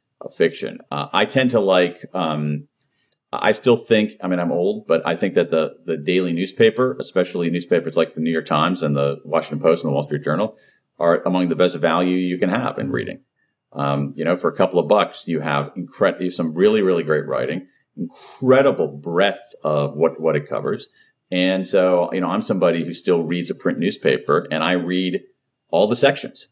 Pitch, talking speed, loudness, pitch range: 90 Hz, 205 wpm, -20 LUFS, 80-95 Hz